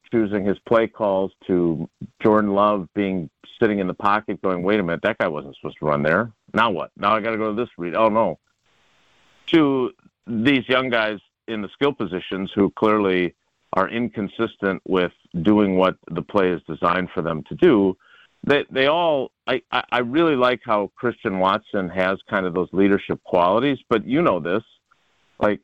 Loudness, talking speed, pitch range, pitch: -21 LUFS, 185 wpm, 90-110 Hz, 100 Hz